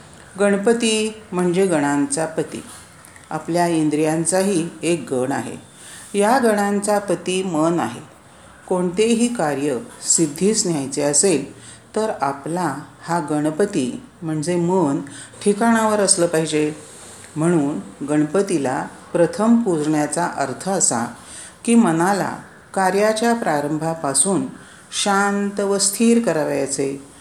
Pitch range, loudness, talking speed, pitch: 150-200 Hz, -19 LUFS, 95 wpm, 170 Hz